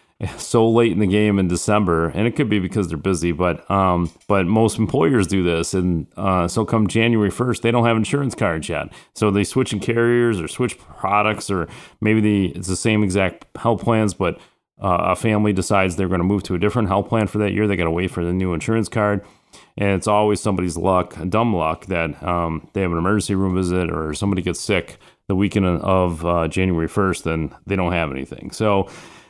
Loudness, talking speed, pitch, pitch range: -20 LUFS, 220 wpm, 100 Hz, 90-110 Hz